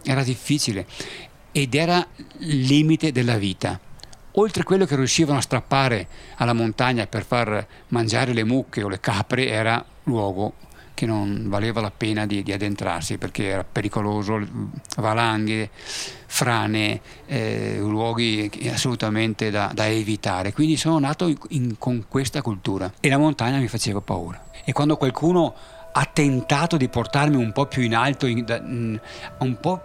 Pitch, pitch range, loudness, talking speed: 120 Hz, 105-140 Hz, -23 LUFS, 150 wpm